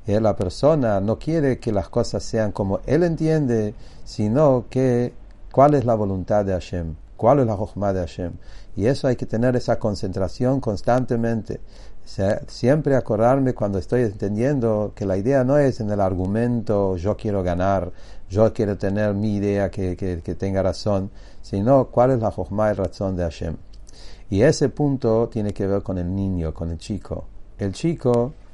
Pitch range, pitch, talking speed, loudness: 95-120 Hz, 105 Hz, 175 wpm, -22 LUFS